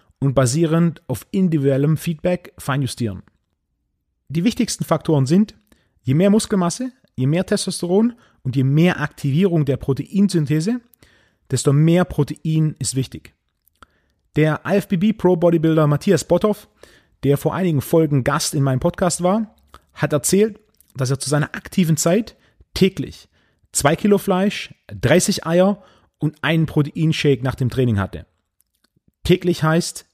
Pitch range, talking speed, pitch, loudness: 140-185 Hz, 130 wpm, 160 Hz, -19 LUFS